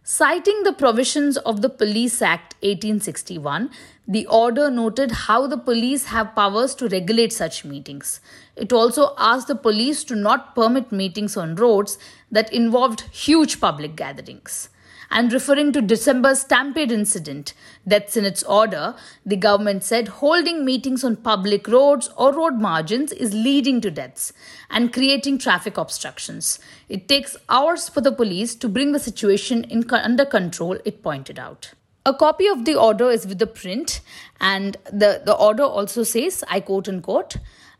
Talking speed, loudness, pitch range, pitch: 155 wpm, -19 LUFS, 205-275 Hz, 230 Hz